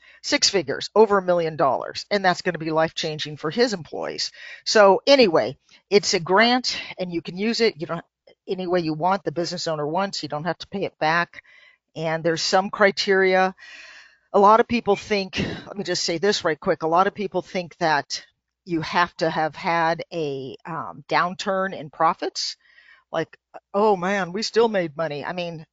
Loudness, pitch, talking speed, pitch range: -22 LUFS, 180 Hz, 195 wpm, 165-200 Hz